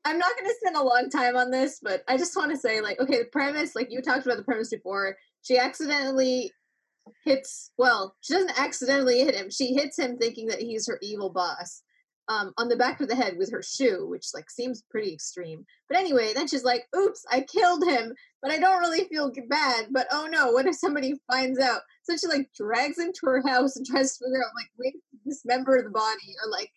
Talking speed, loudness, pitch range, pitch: 235 wpm, -26 LUFS, 240-300 Hz, 260 Hz